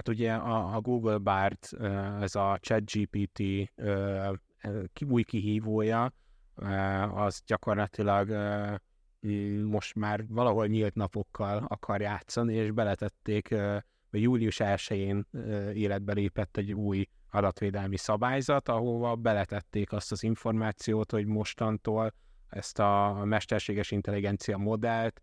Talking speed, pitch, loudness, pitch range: 100 wpm, 105 Hz, -31 LUFS, 100-110 Hz